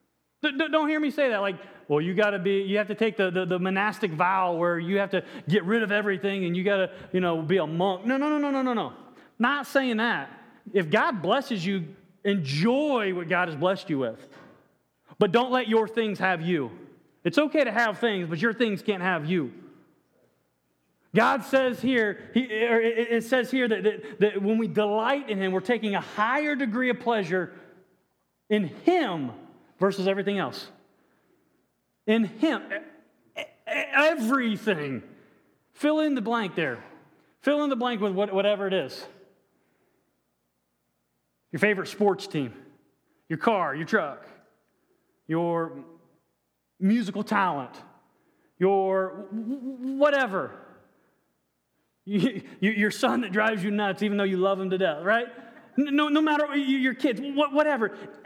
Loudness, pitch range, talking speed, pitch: -26 LUFS, 190-250 Hz, 155 wpm, 210 Hz